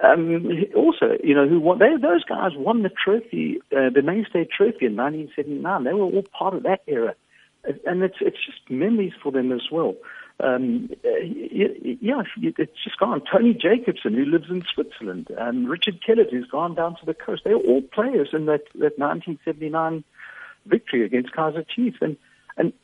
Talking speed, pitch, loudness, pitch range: 195 wpm, 185 Hz, -22 LUFS, 155-240 Hz